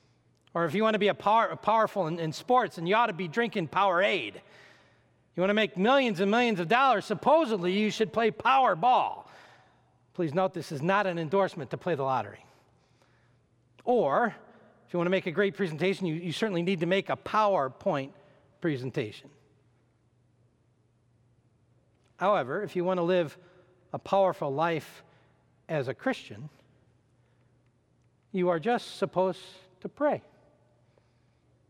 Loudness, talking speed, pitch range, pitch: -28 LUFS, 155 wpm, 135-200 Hz, 180 Hz